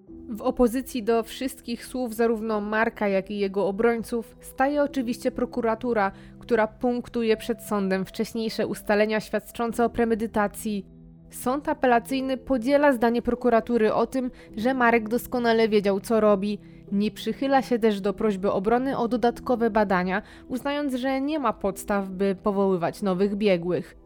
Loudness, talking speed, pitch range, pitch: -25 LUFS, 135 wpm, 205-245 Hz, 225 Hz